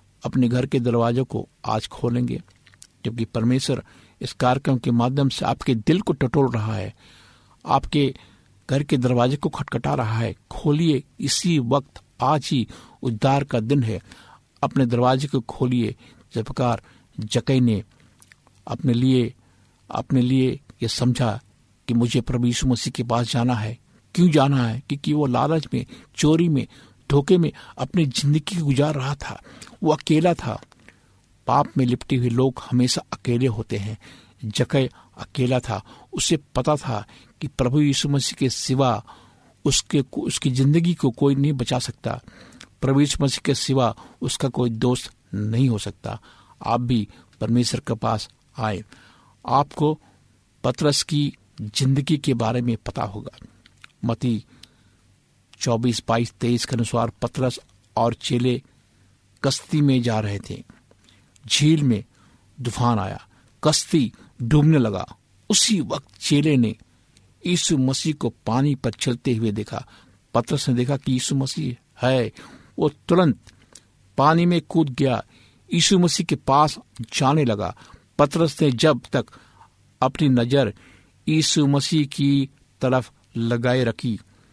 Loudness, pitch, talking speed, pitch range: -22 LUFS, 125 Hz, 140 wpm, 115-140 Hz